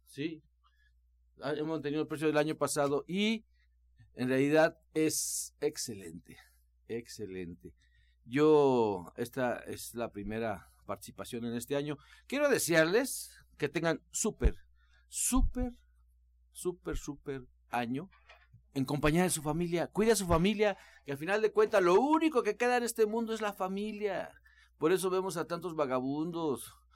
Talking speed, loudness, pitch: 140 wpm, -32 LUFS, 150 Hz